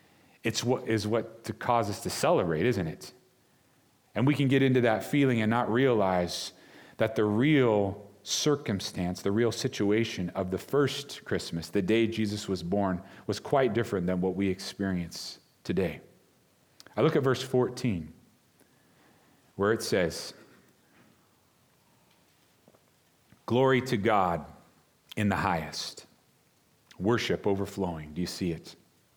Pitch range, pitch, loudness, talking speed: 95-125 Hz, 110 Hz, -29 LUFS, 135 wpm